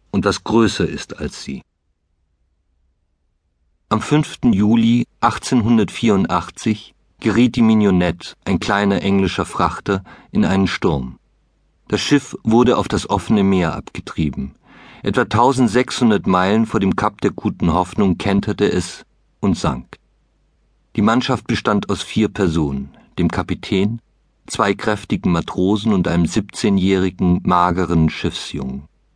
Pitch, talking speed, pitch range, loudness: 100 Hz, 115 wpm, 85-110 Hz, -18 LUFS